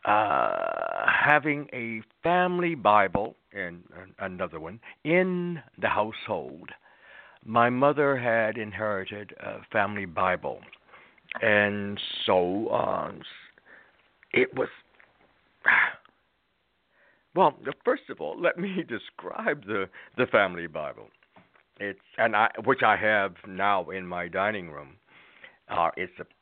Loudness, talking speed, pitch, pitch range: -26 LUFS, 110 wpm, 120 Hz, 105-175 Hz